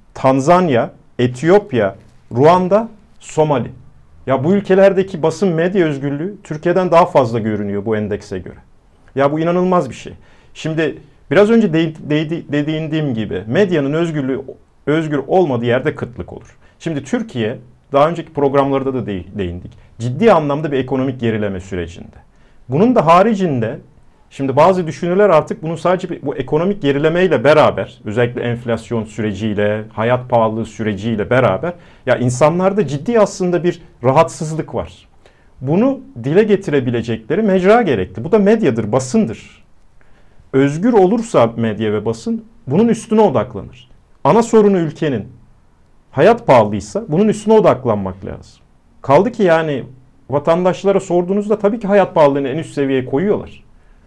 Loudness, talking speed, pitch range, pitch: -15 LUFS, 130 wpm, 115-185 Hz, 150 Hz